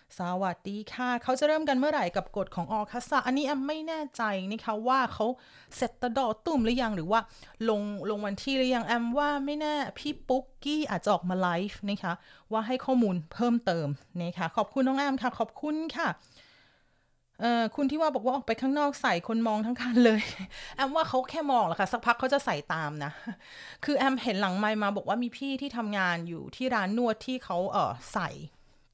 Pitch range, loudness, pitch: 200-270 Hz, -30 LUFS, 235 Hz